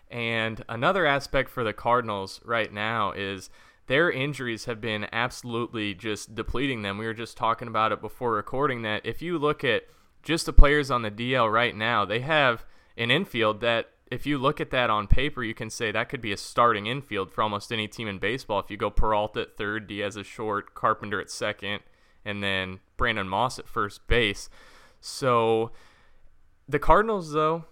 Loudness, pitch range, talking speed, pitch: -27 LUFS, 105-130 Hz, 190 wpm, 115 Hz